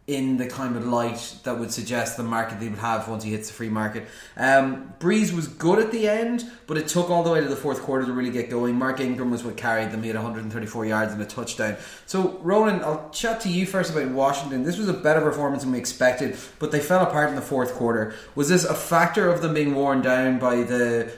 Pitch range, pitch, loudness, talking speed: 120-155 Hz, 130 Hz, -24 LUFS, 250 wpm